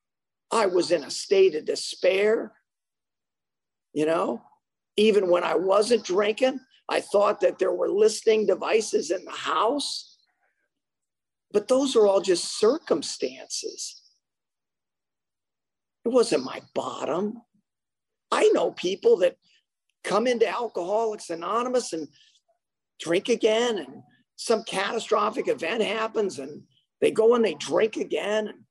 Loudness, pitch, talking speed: -24 LUFS, 225 Hz, 120 wpm